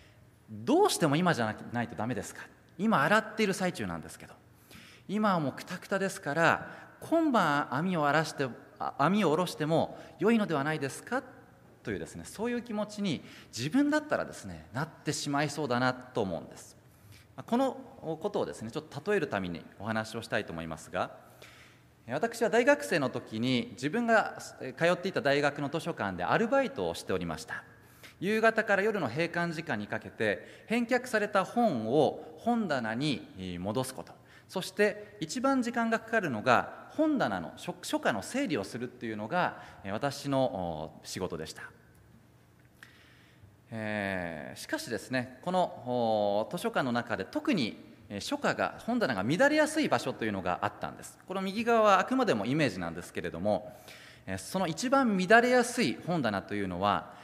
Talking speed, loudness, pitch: 330 characters per minute, -31 LUFS, 155 Hz